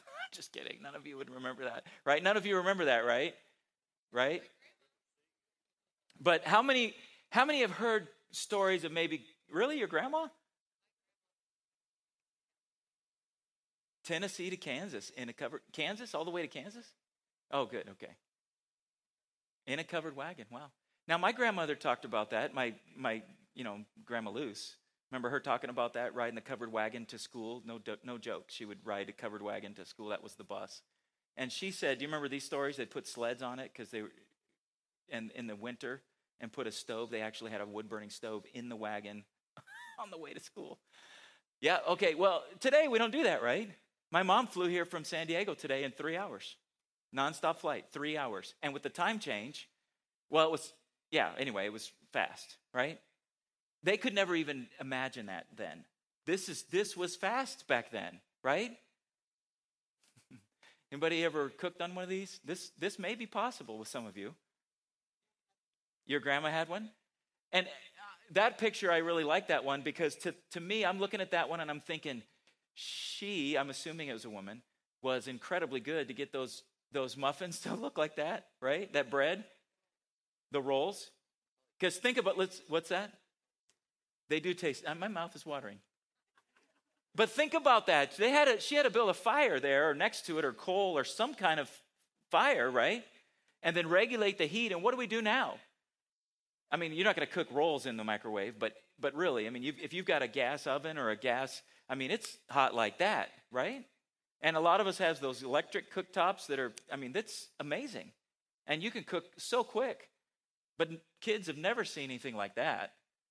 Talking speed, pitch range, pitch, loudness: 185 wpm, 135-195 Hz, 160 Hz, -35 LUFS